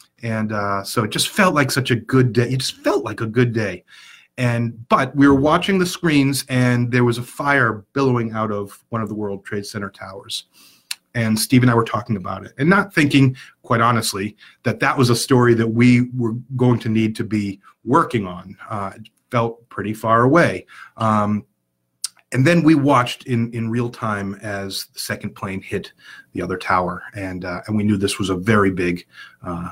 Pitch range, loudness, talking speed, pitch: 100-125 Hz, -19 LUFS, 205 wpm, 115 Hz